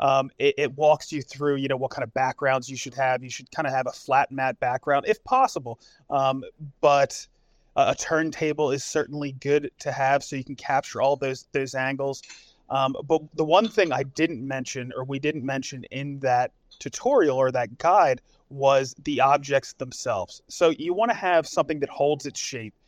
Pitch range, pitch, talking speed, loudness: 130-150 Hz, 140 Hz, 200 wpm, -25 LUFS